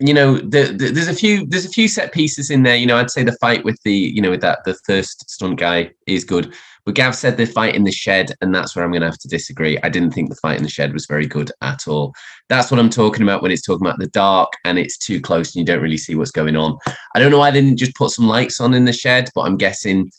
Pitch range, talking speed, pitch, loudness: 90-130 Hz, 305 wpm, 110 Hz, -16 LUFS